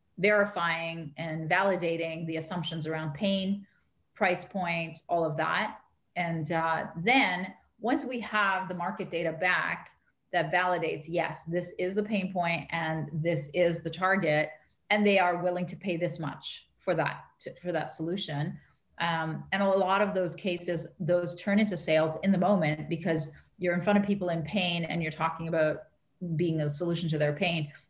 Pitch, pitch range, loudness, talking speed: 170 Hz, 160-185 Hz, -29 LUFS, 175 wpm